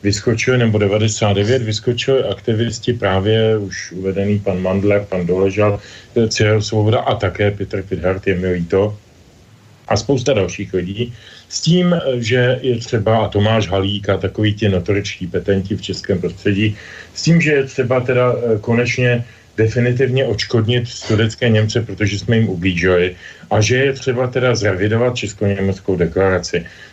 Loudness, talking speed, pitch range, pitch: -17 LUFS, 145 wpm, 100-120 Hz, 110 Hz